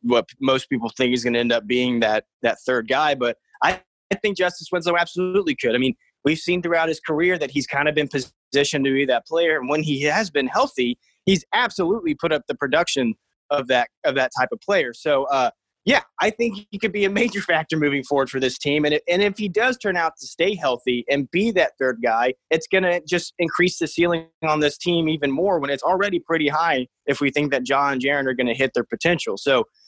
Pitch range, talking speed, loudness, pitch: 135-180 Hz, 235 wpm, -21 LUFS, 150 Hz